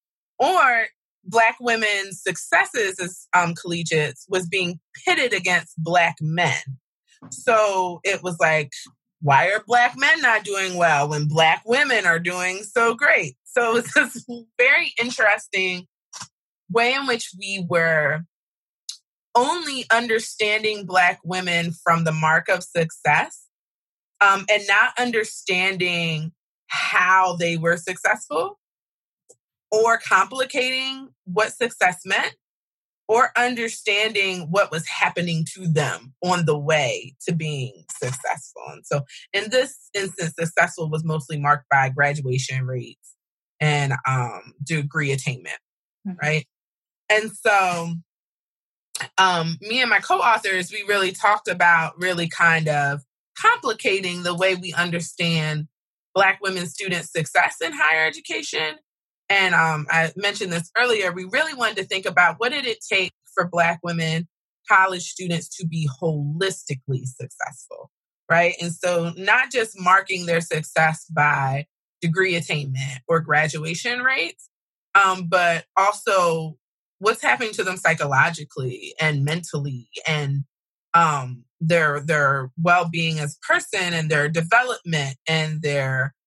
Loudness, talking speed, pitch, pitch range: -21 LUFS, 125 wpm, 175 Hz, 155-200 Hz